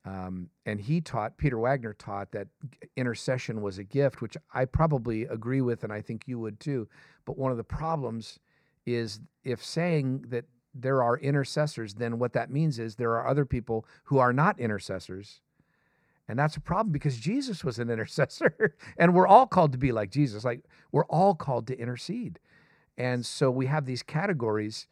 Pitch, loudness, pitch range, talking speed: 125 Hz, -28 LUFS, 115-145 Hz, 185 wpm